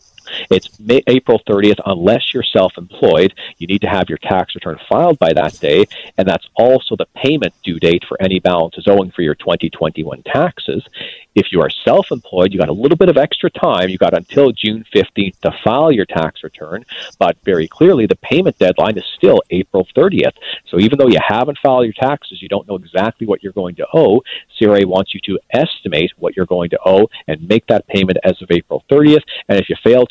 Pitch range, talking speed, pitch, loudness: 95-125 Hz, 210 wpm, 100 Hz, -14 LUFS